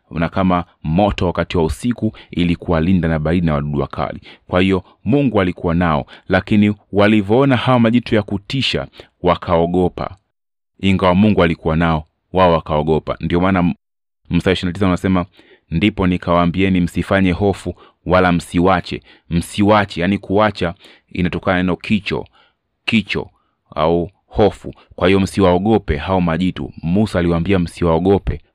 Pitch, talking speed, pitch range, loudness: 90 Hz, 120 wpm, 85-100 Hz, -17 LUFS